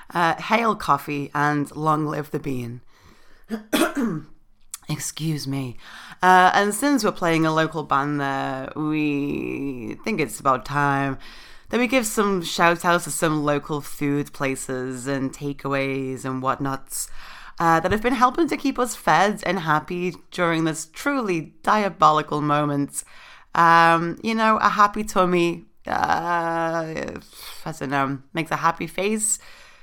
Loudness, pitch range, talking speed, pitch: -22 LUFS, 140-185 Hz, 135 wpm, 155 Hz